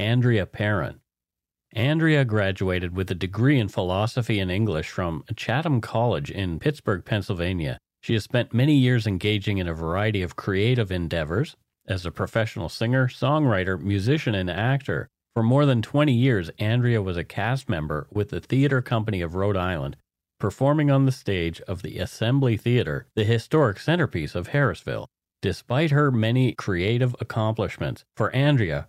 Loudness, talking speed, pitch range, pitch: -24 LUFS, 155 wpm, 95-130 Hz, 110 Hz